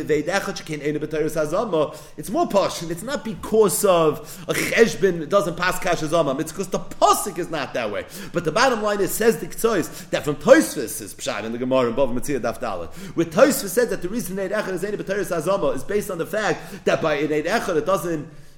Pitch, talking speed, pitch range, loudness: 175 Hz, 195 wpm, 155-200 Hz, -22 LUFS